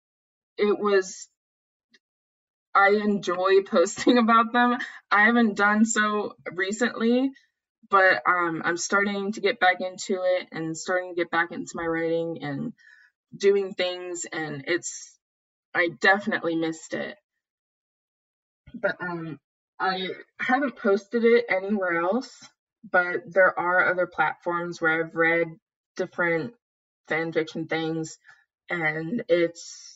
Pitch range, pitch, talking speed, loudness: 170-210 Hz, 185 Hz, 120 wpm, -24 LUFS